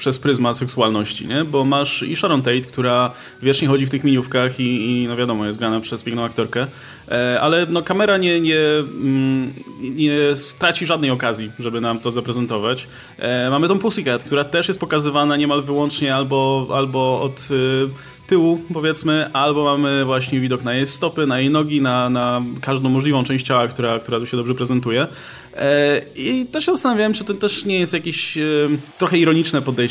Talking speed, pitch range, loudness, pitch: 170 wpm, 125-150 Hz, -18 LUFS, 135 Hz